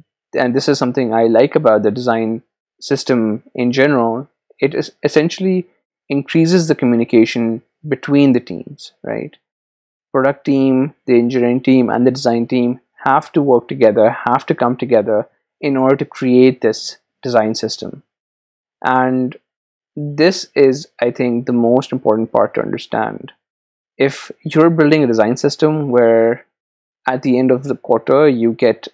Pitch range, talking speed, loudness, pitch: 120-140 Hz, 150 wpm, -15 LUFS, 130 Hz